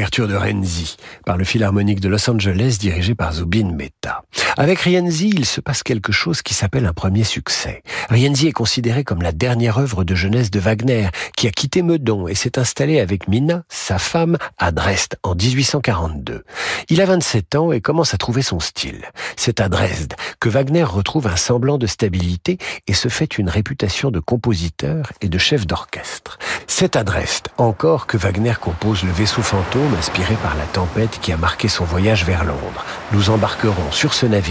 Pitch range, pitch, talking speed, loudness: 95-135 Hz, 110 Hz, 190 wpm, -18 LUFS